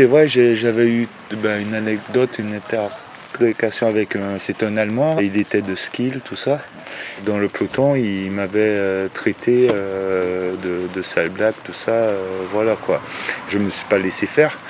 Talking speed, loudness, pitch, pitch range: 175 wpm, -19 LUFS, 105 Hz, 100-115 Hz